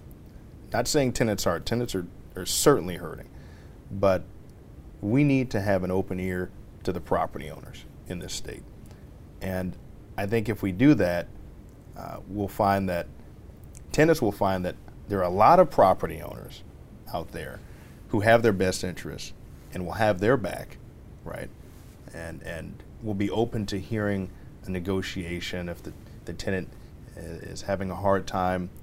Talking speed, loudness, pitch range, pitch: 160 wpm, -26 LUFS, 90-110 Hz, 95 Hz